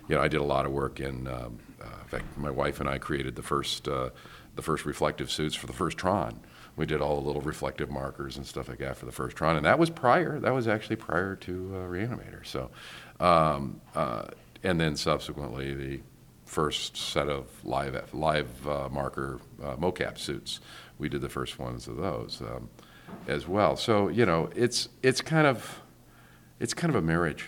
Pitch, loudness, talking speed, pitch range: 75 Hz, -30 LUFS, 205 wpm, 70-105 Hz